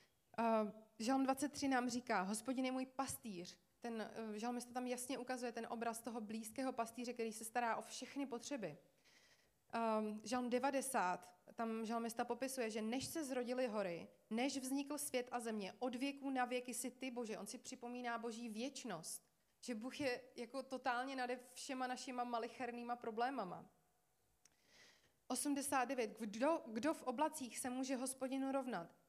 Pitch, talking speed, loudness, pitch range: 245 Hz, 150 wpm, -44 LUFS, 230-260 Hz